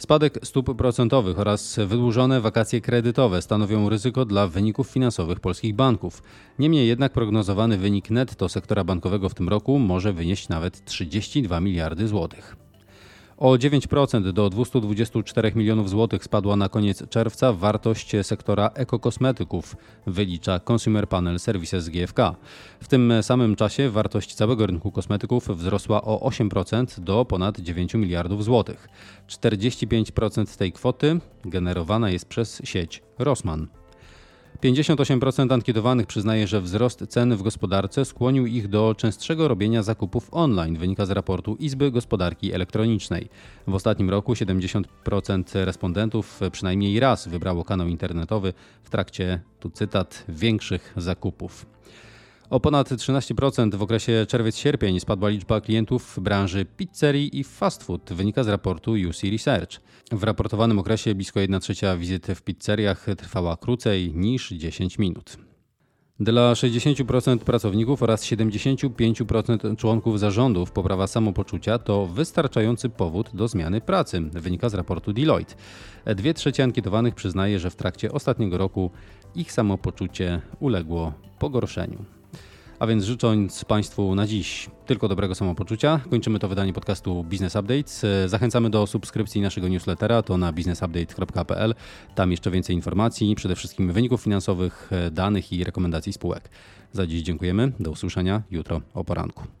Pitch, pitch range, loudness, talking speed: 105 Hz, 95-120 Hz, -24 LUFS, 130 wpm